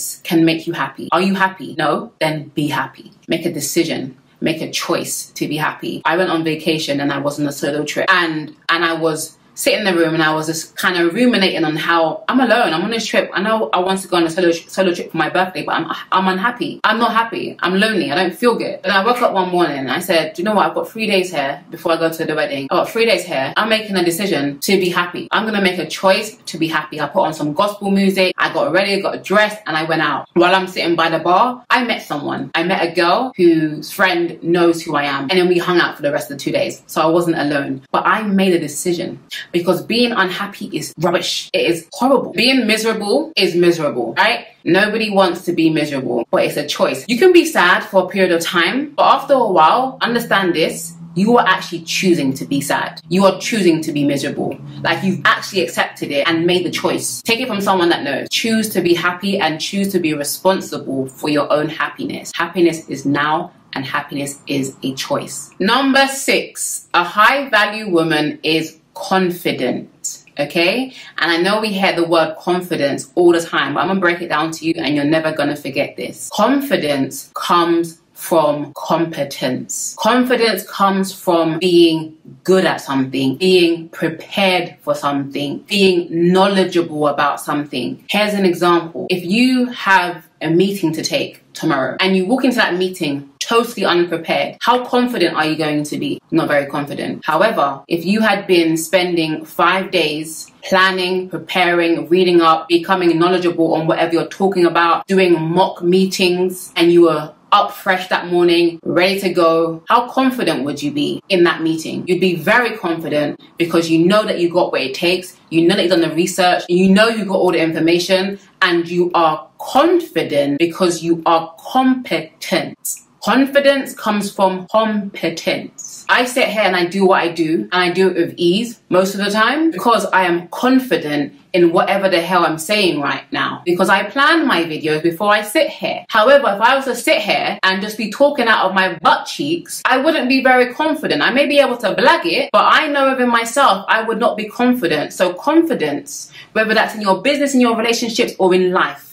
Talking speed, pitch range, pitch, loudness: 210 wpm, 165-205 Hz, 180 Hz, -16 LUFS